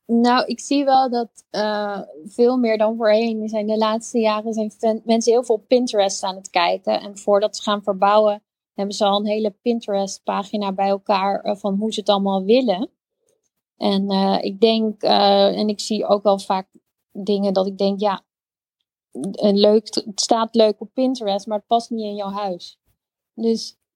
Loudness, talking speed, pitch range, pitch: -20 LUFS, 180 wpm, 200-225 Hz, 210 Hz